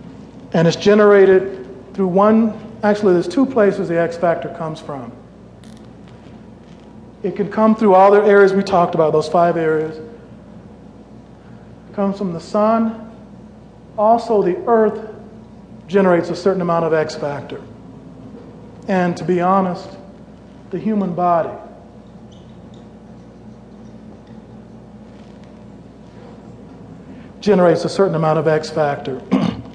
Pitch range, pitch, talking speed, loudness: 170-210 Hz, 190 Hz, 115 wpm, -16 LUFS